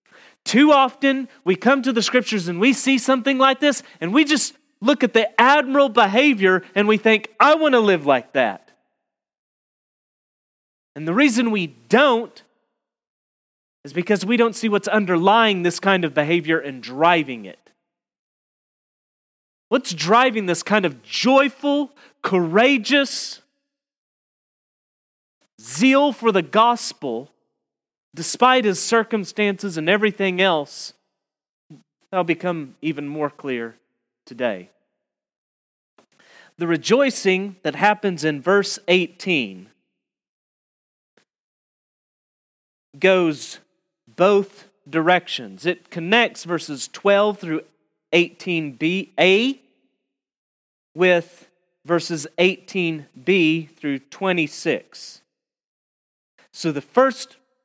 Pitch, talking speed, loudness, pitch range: 190 Hz, 105 wpm, -19 LUFS, 160-245 Hz